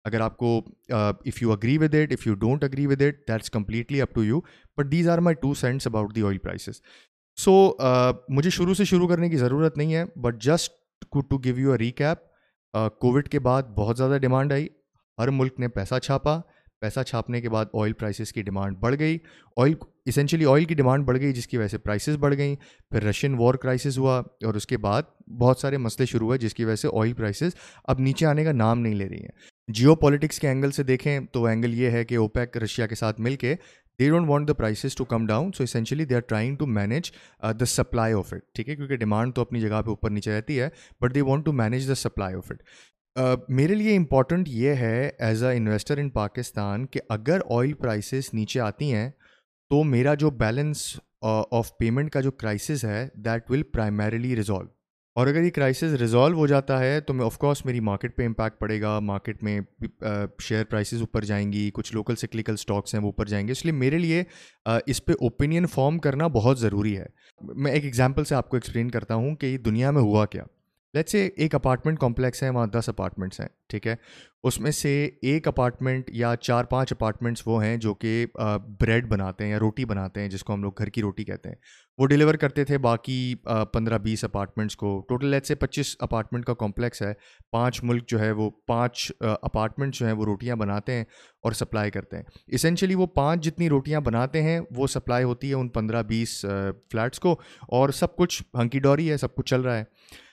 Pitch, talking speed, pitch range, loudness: 125 Hz, 215 wpm, 110-140 Hz, -25 LUFS